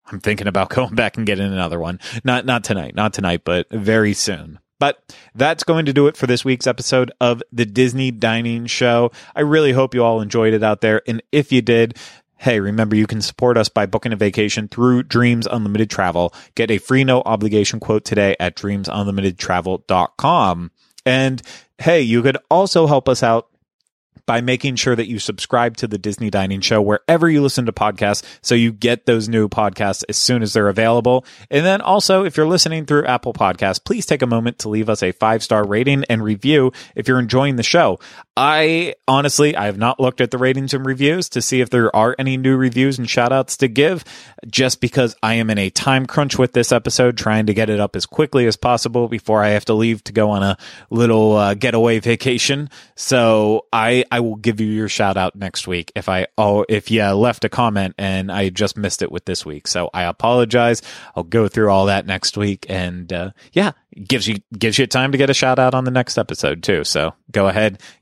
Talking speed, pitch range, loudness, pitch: 215 wpm, 105-130 Hz, -17 LUFS, 115 Hz